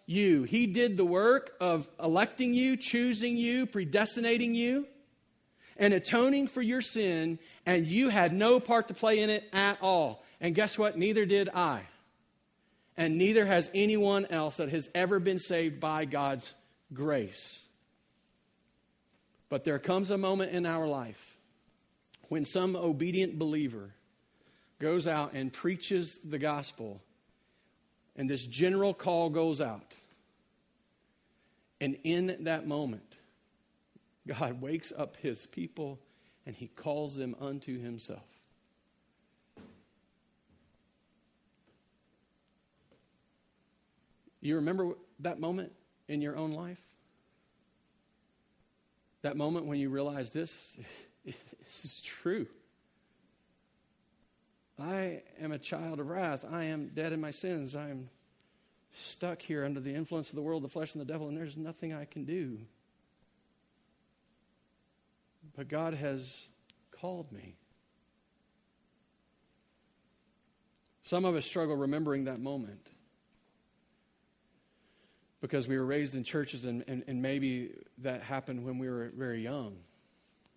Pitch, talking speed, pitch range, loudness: 160 Hz, 120 wpm, 140-185 Hz, -32 LUFS